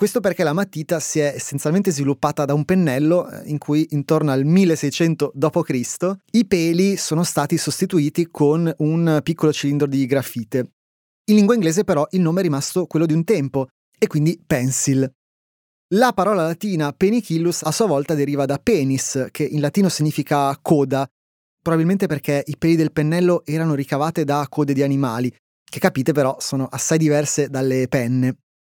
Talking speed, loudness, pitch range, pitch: 165 wpm, -19 LUFS, 140-170 Hz, 155 Hz